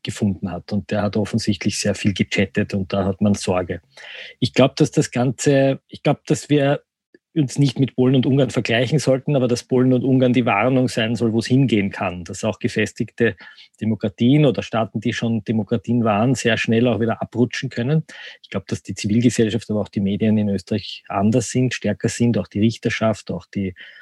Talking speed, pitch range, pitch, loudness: 200 wpm, 105-125 Hz, 115 Hz, -20 LUFS